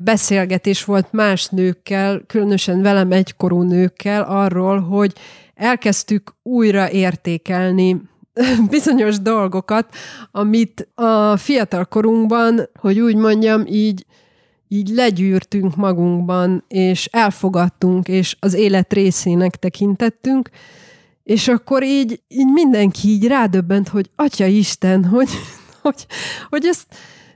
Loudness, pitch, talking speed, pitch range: -16 LUFS, 200 Hz, 105 wpm, 185-225 Hz